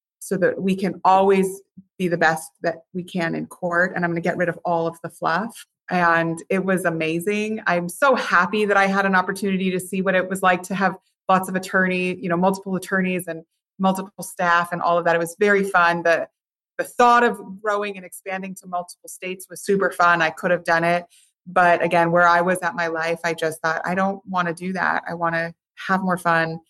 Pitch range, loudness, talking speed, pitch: 170-190 Hz, -21 LUFS, 230 wpm, 180 Hz